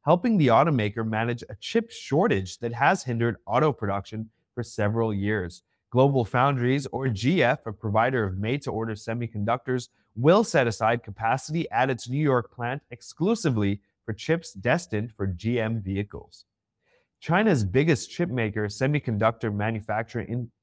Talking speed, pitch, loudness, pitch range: 135 wpm, 115 Hz, -25 LUFS, 110-135 Hz